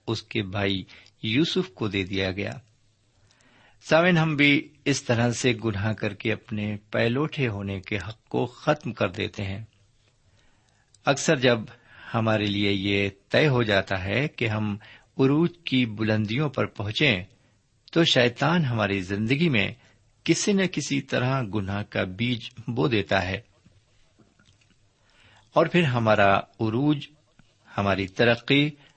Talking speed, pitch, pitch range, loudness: 135 wpm, 110 Hz, 105-135 Hz, -25 LUFS